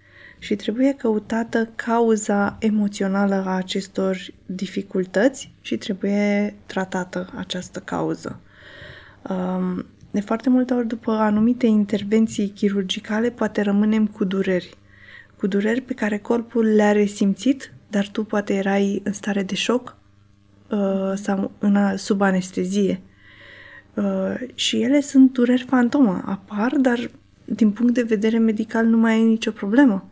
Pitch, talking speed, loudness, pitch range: 210 Hz, 120 wpm, -21 LUFS, 195-230 Hz